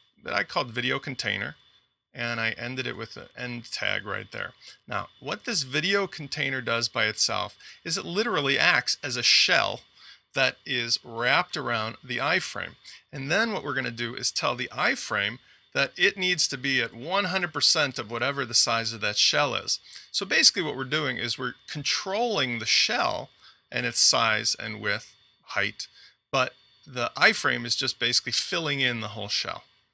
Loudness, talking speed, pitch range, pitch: -25 LUFS, 180 wpm, 115-145 Hz, 125 Hz